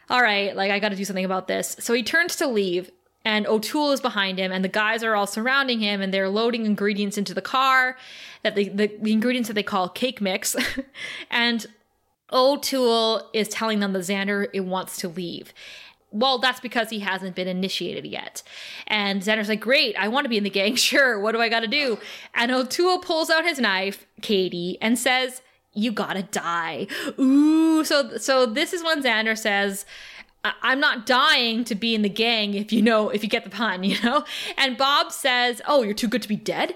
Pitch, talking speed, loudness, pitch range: 225 Hz, 210 wpm, -22 LUFS, 200-260 Hz